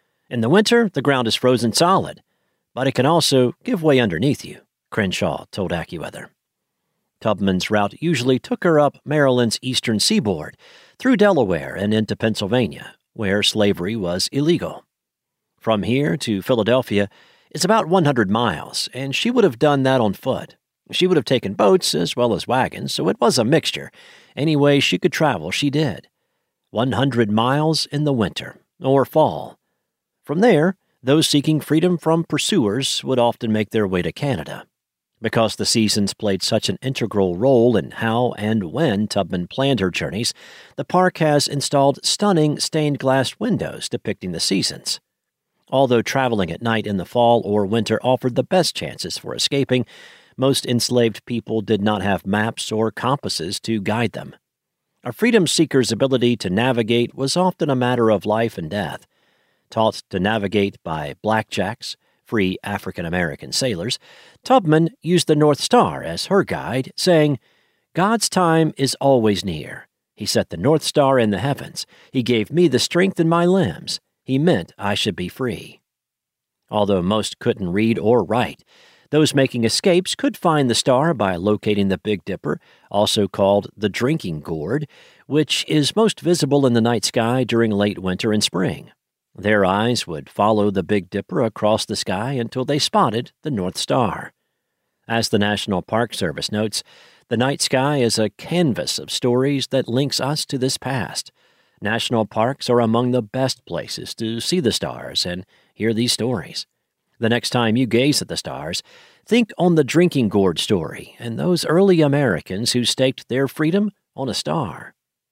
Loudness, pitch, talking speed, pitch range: -19 LUFS, 125 Hz, 165 wpm, 110-150 Hz